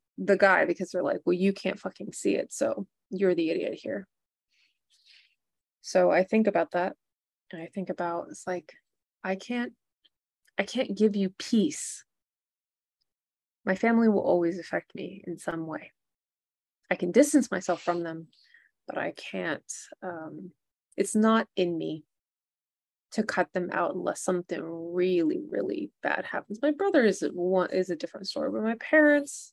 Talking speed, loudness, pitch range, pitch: 160 wpm, -28 LUFS, 175-220 Hz, 185 Hz